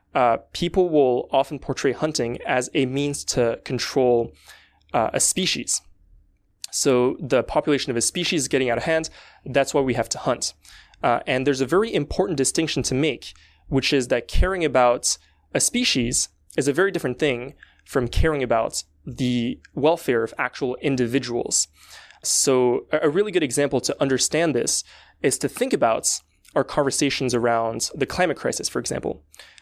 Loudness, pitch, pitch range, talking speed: -22 LUFS, 130 Hz, 120-145 Hz, 160 wpm